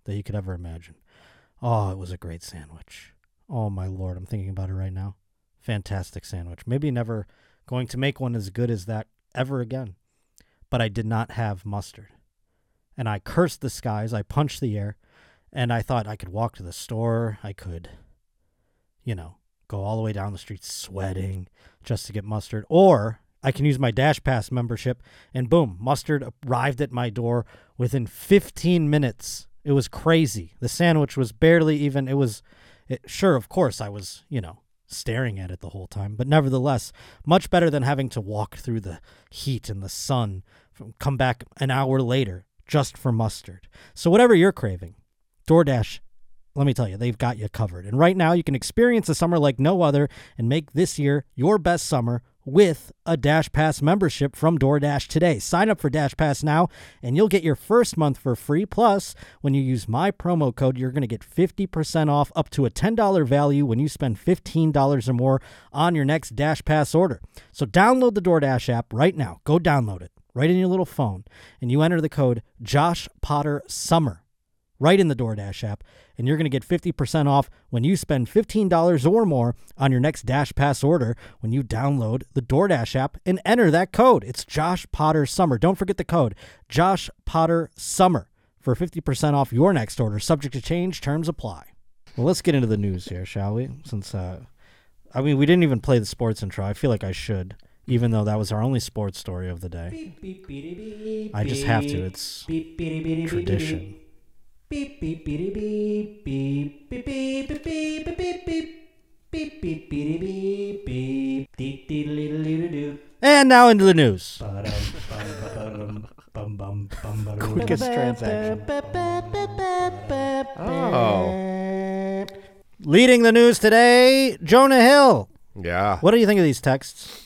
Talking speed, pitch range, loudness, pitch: 170 wpm, 110-165 Hz, -22 LUFS, 135 Hz